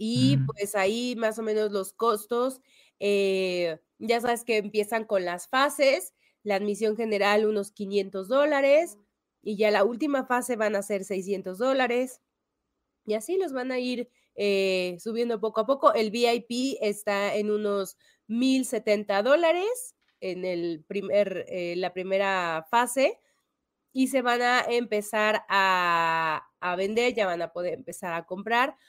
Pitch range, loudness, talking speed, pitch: 195-245 Hz, -26 LUFS, 150 wpm, 215 Hz